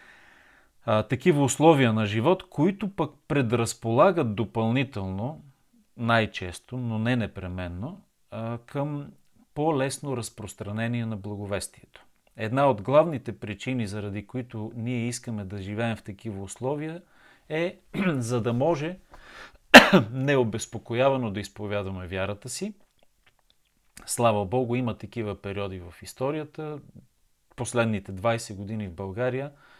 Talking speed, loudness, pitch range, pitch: 105 wpm, -26 LUFS, 105-140 Hz, 120 Hz